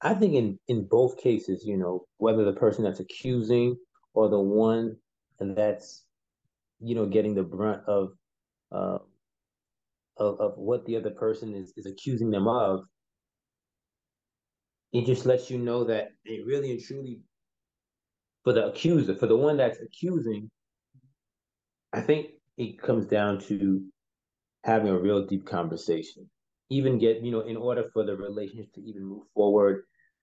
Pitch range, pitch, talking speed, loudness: 100-125 Hz, 110 Hz, 155 wpm, -27 LUFS